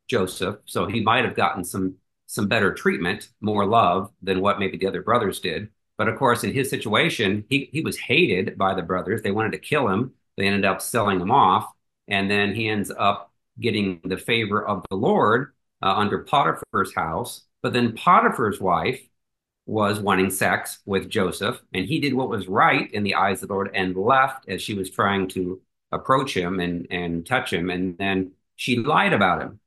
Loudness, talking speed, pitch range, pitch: -22 LUFS, 200 wpm, 95-110 Hz, 100 Hz